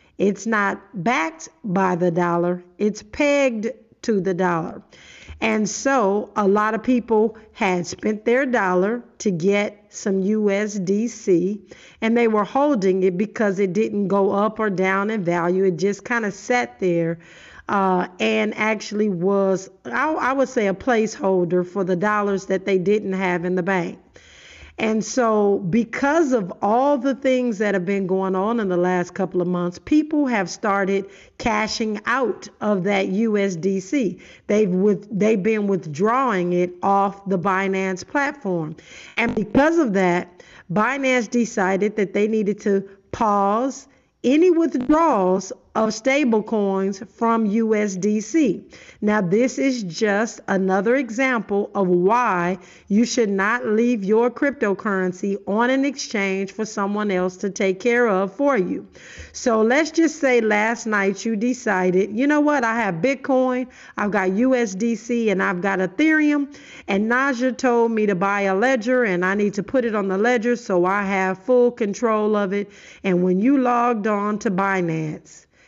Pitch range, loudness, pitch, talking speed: 190-235 Hz, -20 LUFS, 210 Hz, 155 wpm